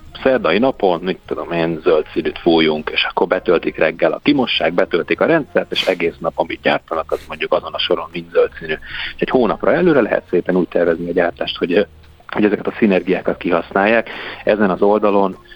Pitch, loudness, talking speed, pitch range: 90 Hz, -17 LUFS, 180 wpm, 85-105 Hz